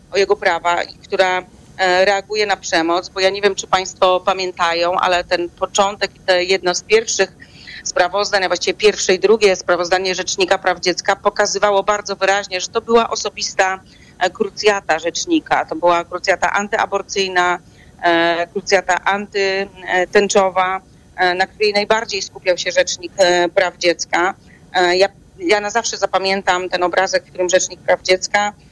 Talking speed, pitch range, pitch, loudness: 140 wpm, 180-200 Hz, 190 Hz, -17 LUFS